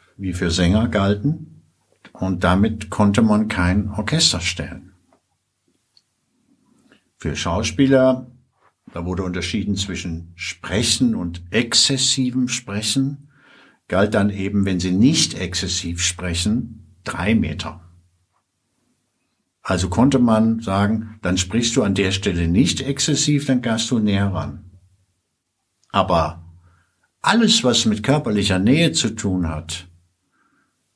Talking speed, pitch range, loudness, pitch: 110 wpm, 90-115 Hz, -19 LUFS, 100 Hz